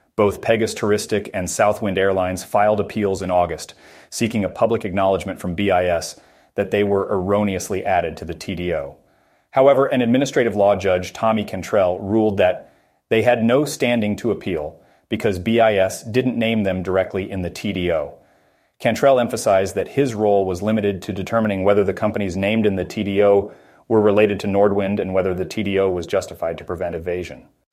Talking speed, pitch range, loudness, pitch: 165 wpm, 95-105 Hz, -19 LUFS, 100 Hz